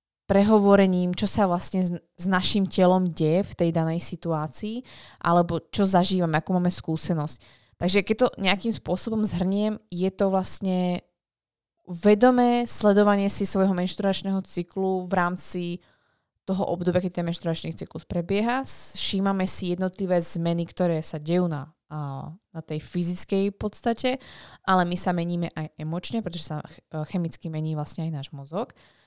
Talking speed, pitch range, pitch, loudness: 140 wpm, 170-195 Hz, 180 Hz, -24 LUFS